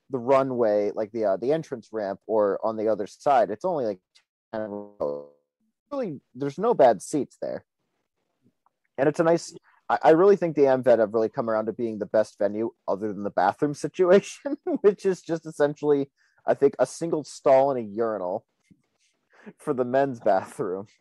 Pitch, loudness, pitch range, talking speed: 135 Hz, -24 LUFS, 110-165 Hz, 180 wpm